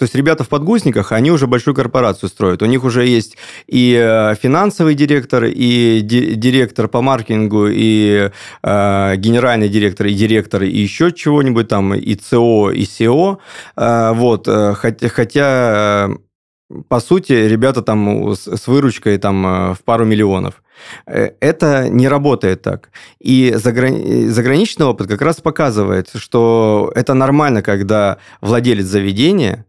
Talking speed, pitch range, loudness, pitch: 130 wpm, 105-130 Hz, -13 LUFS, 115 Hz